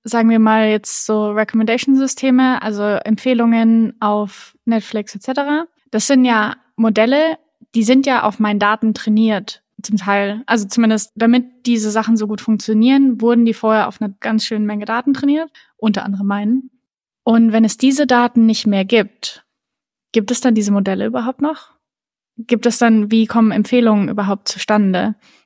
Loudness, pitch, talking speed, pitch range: -15 LUFS, 225 Hz, 160 wpm, 215-245 Hz